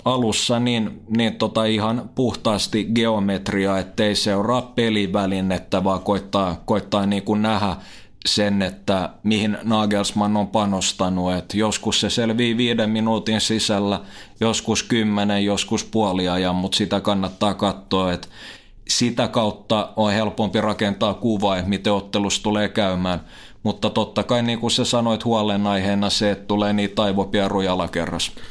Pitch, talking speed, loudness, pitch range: 105 Hz, 130 wpm, -21 LUFS, 100-110 Hz